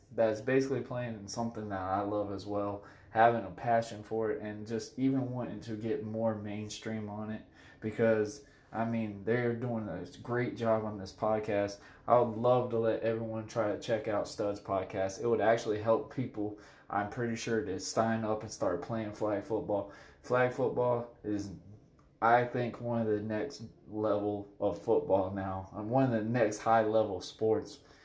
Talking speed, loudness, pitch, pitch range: 180 wpm, -33 LUFS, 110 Hz, 105-120 Hz